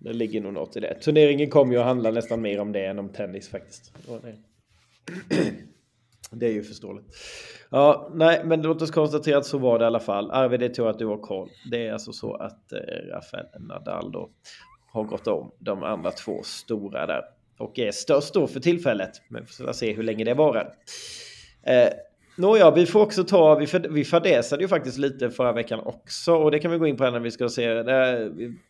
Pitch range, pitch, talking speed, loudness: 115-160 Hz, 130 Hz, 215 wpm, -23 LUFS